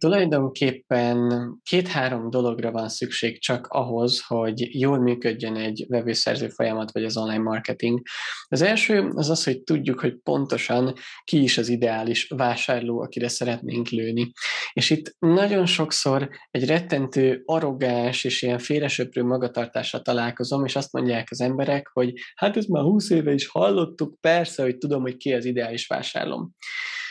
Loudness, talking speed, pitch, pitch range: -24 LUFS, 145 wpm, 125 Hz, 120-150 Hz